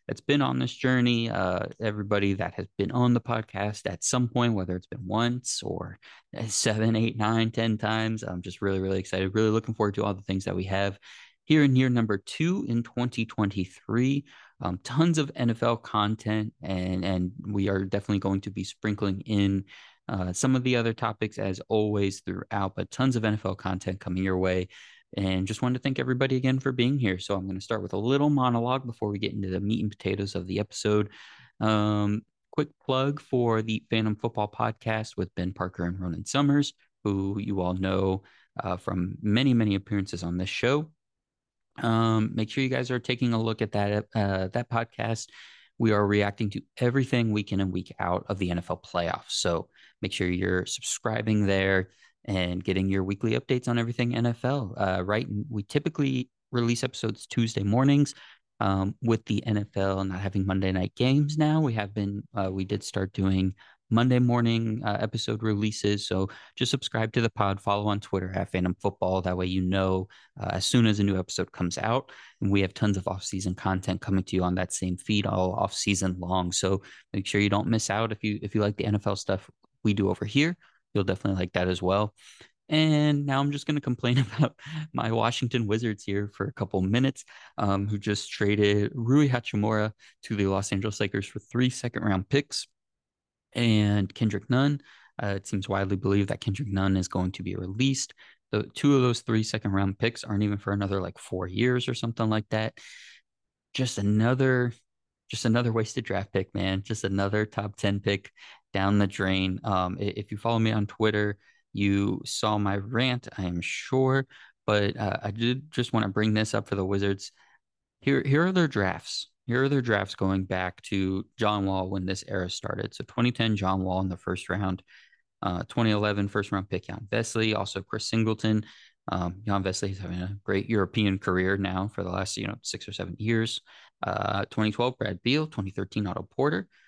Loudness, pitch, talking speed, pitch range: -28 LUFS, 105 Hz, 195 wpm, 95-115 Hz